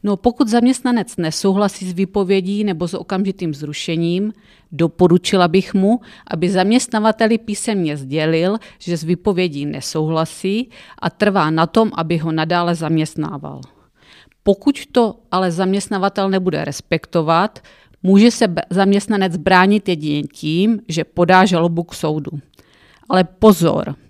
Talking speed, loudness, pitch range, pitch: 120 wpm, -17 LUFS, 165-205 Hz, 185 Hz